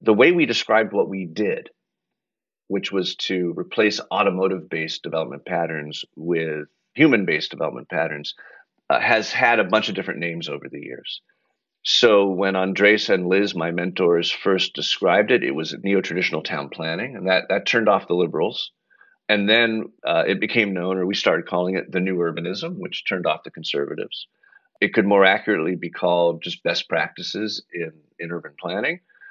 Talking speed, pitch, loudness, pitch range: 175 wpm, 95 Hz, -21 LUFS, 85-105 Hz